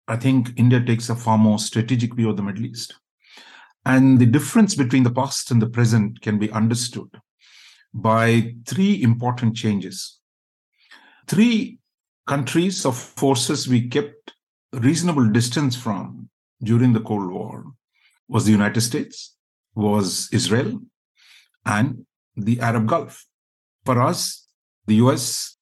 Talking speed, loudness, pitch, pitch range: 135 wpm, -20 LUFS, 120 Hz, 110-135 Hz